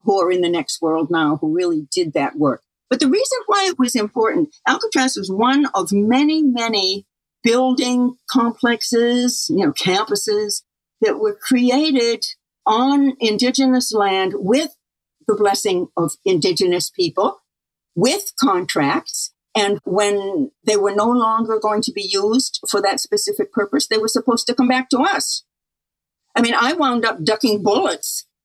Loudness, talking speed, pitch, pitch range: -18 LUFS, 155 wpm, 250 Hz, 215-305 Hz